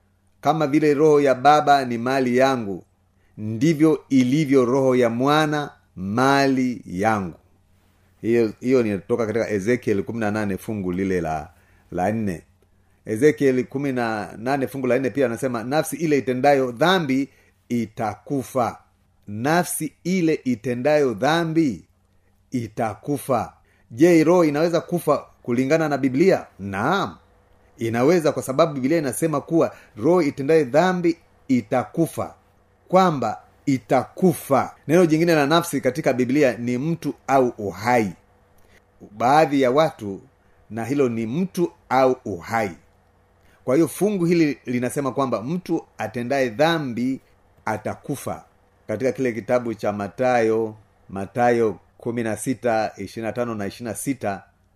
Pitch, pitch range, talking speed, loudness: 125 Hz, 100-145 Hz, 120 wpm, -21 LUFS